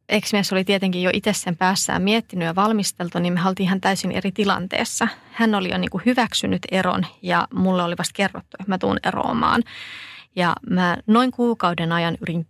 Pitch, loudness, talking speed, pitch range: 190 Hz, -21 LUFS, 185 wpm, 180-205 Hz